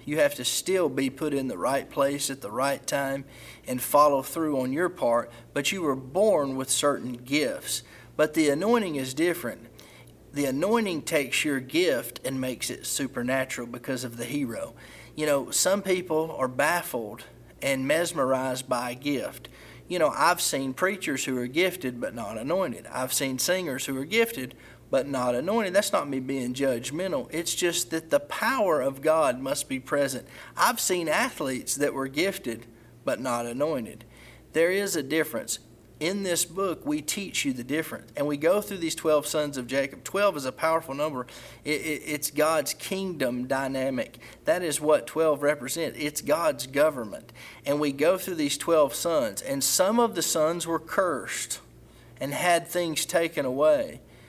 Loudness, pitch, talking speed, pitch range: -27 LUFS, 145 Hz, 175 wpm, 130-165 Hz